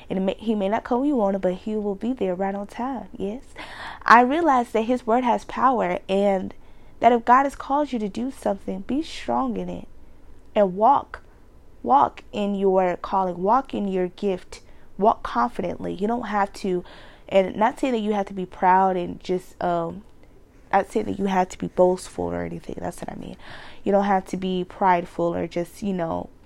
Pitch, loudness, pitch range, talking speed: 200 Hz, -23 LUFS, 185-230 Hz, 210 wpm